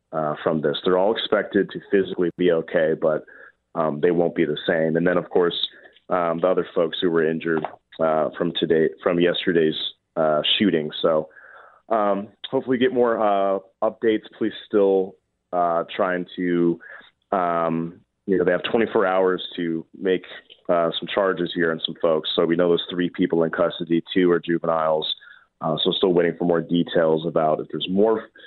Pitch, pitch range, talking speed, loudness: 85 Hz, 80-95 Hz, 180 wpm, -22 LUFS